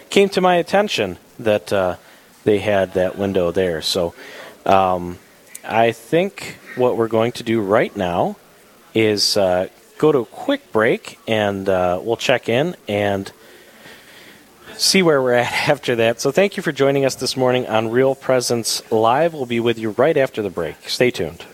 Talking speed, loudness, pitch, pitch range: 175 wpm, -18 LUFS, 115 Hz, 105-140 Hz